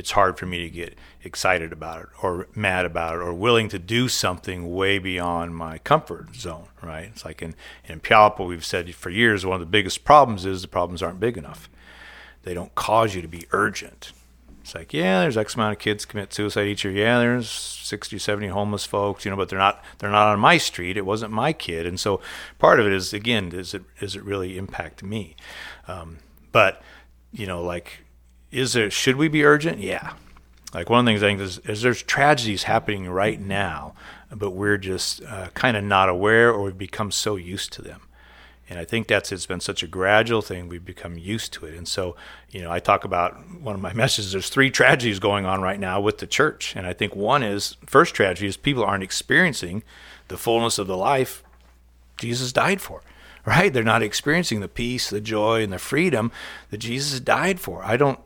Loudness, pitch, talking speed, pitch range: -22 LUFS, 100 Hz, 215 wpm, 90-115 Hz